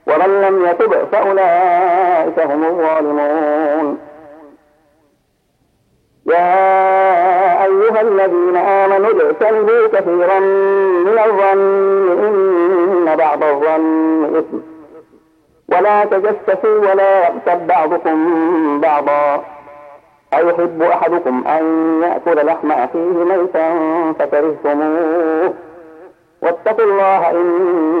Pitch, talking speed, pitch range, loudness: 175 Hz, 75 wpm, 160-195 Hz, -13 LUFS